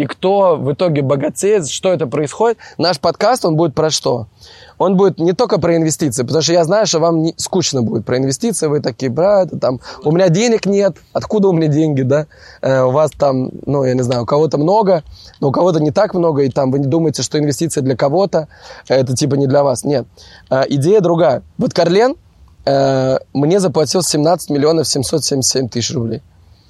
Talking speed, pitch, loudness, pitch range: 200 wpm, 155 Hz, -15 LUFS, 135-180 Hz